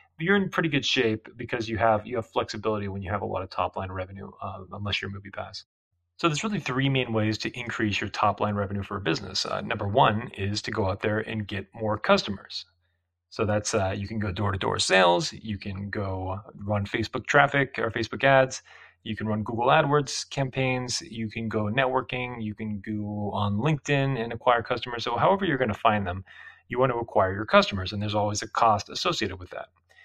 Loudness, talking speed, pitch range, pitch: -26 LUFS, 220 wpm, 100-125 Hz, 110 Hz